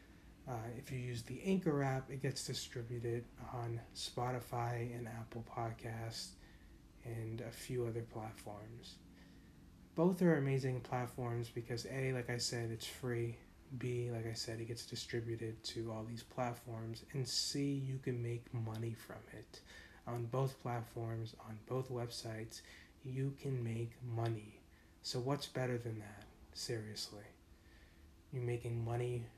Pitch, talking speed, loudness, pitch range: 120 Hz, 140 wpm, -42 LUFS, 110-125 Hz